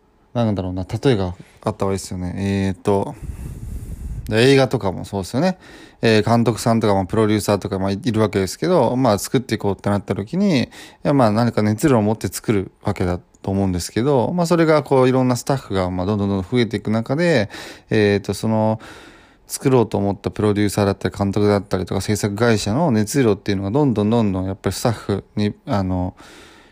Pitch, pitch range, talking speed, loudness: 105 Hz, 100-120 Hz, 435 characters per minute, -19 LUFS